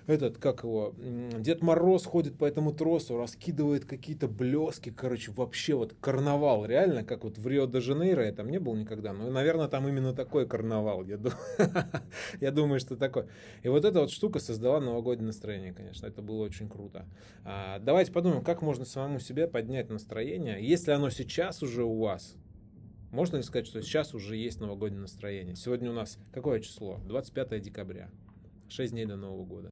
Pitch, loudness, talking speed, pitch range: 120 Hz, -31 LUFS, 170 wpm, 105-145 Hz